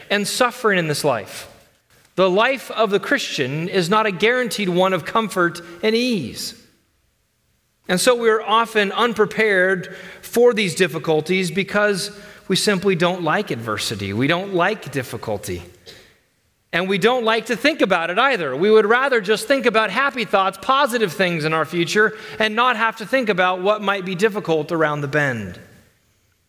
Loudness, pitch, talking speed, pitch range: -19 LUFS, 195 Hz, 165 wpm, 170-220 Hz